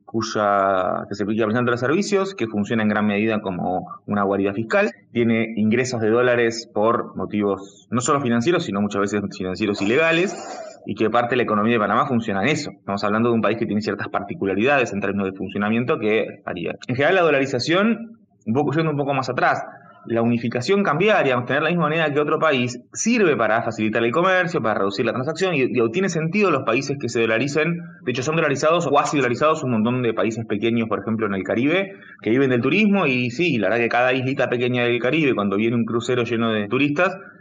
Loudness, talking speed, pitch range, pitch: -20 LUFS, 210 wpm, 110-155 Hz, 120 Hz